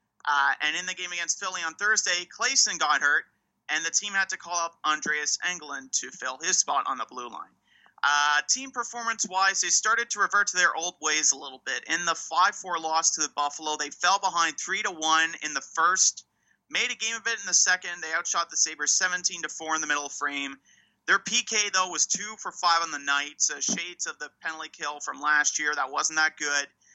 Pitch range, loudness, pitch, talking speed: 150-200 Hz, -25 LUFS, 170 Hz, 220 wpm